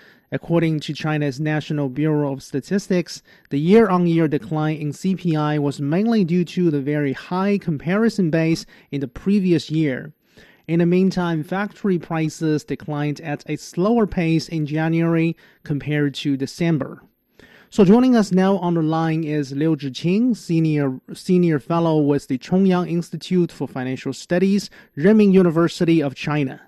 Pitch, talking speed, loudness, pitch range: 165 Hz, 150 wpm, -20 LUFS, 150-180 Hz